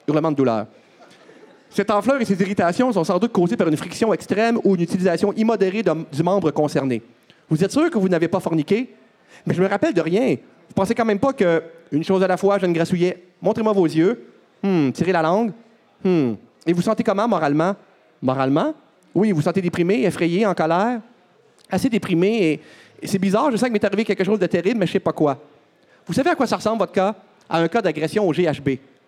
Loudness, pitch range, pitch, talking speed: -20 LUFS, 165-215 Hz, 190 Hz, 225 wpm